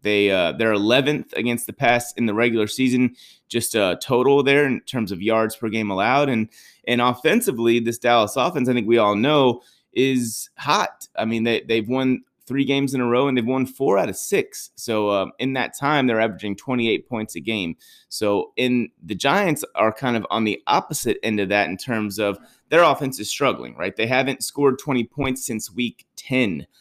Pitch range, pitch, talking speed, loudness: 110-130 Hz, 120 Hz, 210 wpm, -21 LUFS